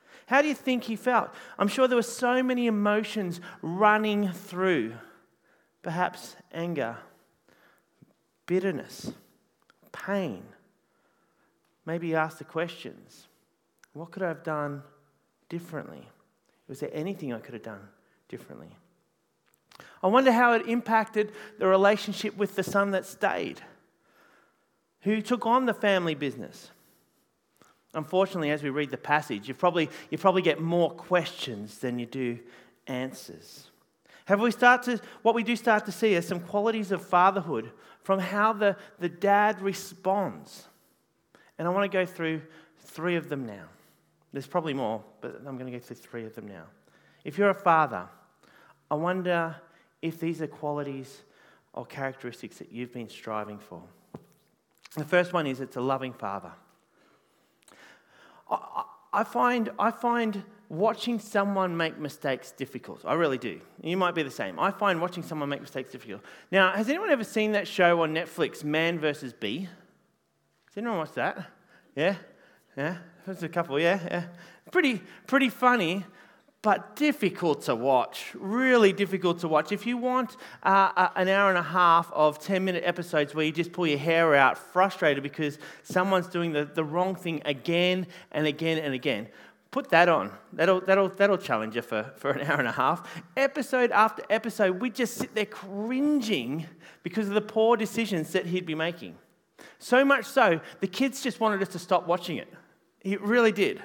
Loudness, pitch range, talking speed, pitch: -27 LUFS, 155-210 Hz, 160 wpm, 180 Hz